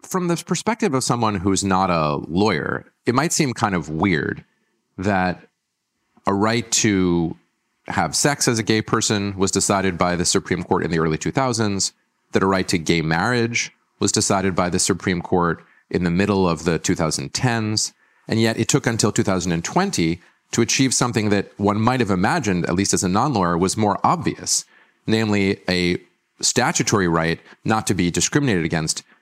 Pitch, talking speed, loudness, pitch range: 100 Hz, 175 wpm, -20 LUFS, 90-115 Hz